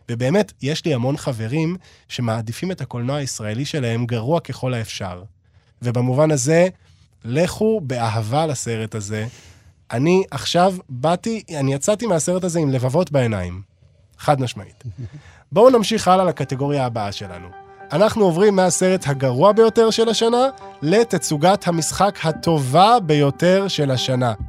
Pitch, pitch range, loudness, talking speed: 145 Hz, 120-185 Hz, -19 LUFS, 125 wpm